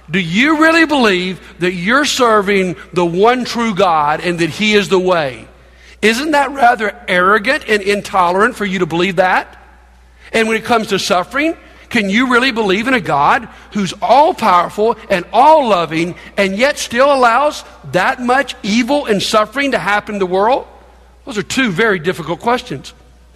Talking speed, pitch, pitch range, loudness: 170 wpm, 205 Hz, 180-245 Hz, -13 LUFS